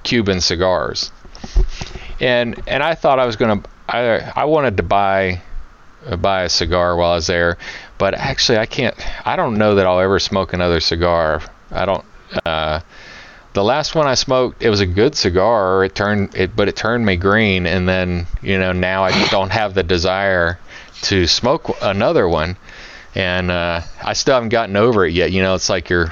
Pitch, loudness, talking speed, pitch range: 95 Hz, -16 LUFS, 190 wpm, 90-100 Hz